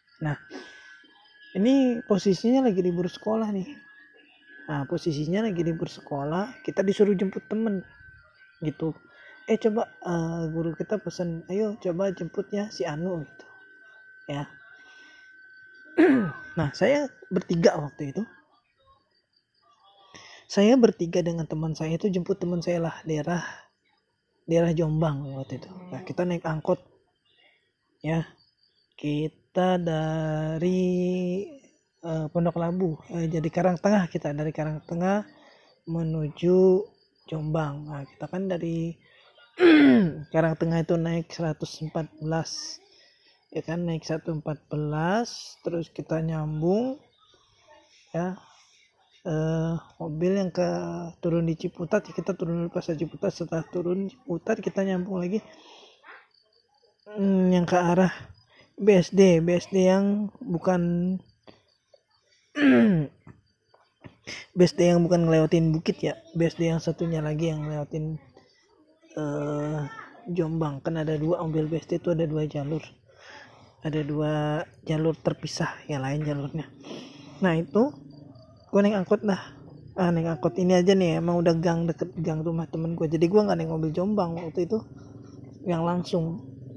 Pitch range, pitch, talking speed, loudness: 155-195 Hz, 170 Hz, 125 wpm, -26 LUFS